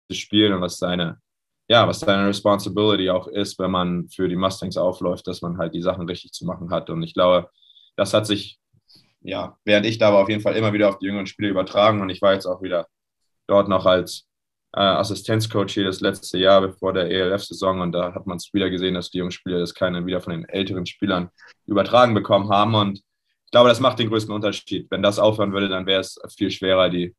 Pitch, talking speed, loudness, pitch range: 95 Hz, 225 wpm, -21 LUFS, 90-100 Hz